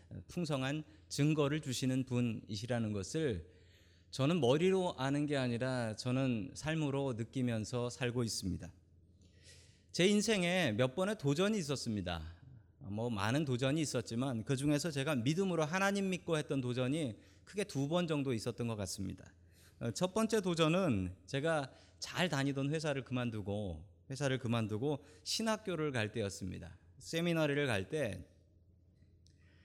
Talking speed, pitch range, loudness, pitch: 290 characters per minute, 100-150 Hz, -36 LUFS, 125 Hz